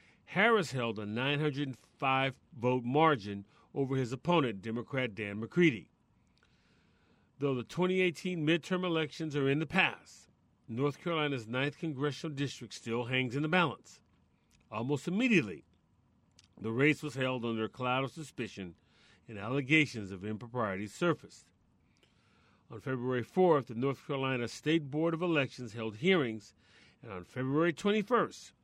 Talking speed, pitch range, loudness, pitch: 130 wpm, 115-155 Hz, -33 LUFS, 130 Hz